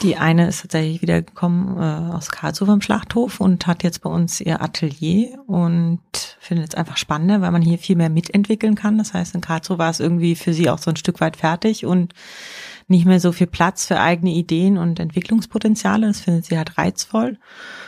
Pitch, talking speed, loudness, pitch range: 175 Hz, 200 wpm, -19 LUFS, 165-200 Hz